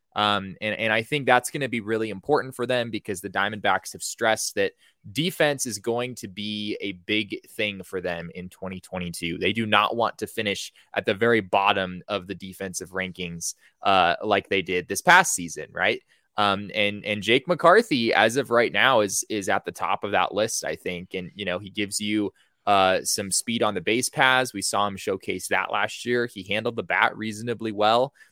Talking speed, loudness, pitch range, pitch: 210 wpm, -24 LUFS, 95-120 Hz, 105 Hz